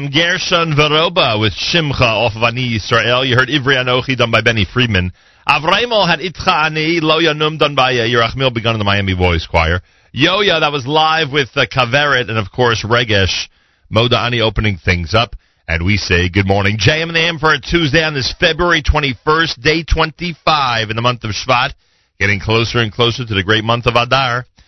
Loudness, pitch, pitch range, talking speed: -13 LUFS, 120 Hz, 110-150 Hz, 185 wpm